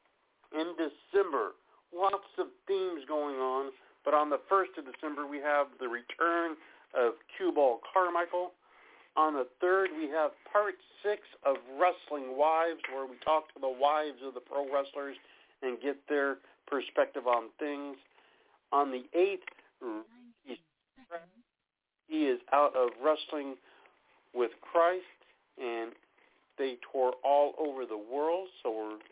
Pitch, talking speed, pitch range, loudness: 150 Hz, 135 wpm, 135-180 Hz, -32 LUFS